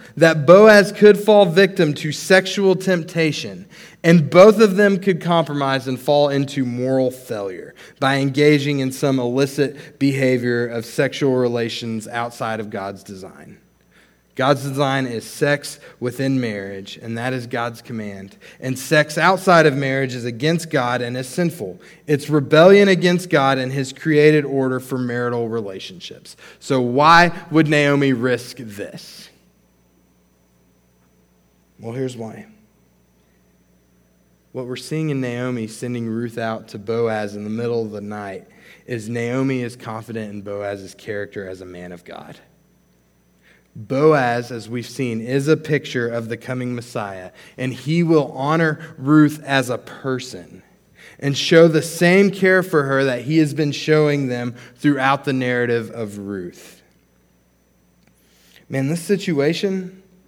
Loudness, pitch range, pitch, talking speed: -18 LUFS, 115-155 Hz, 130 Hz, 140 wpm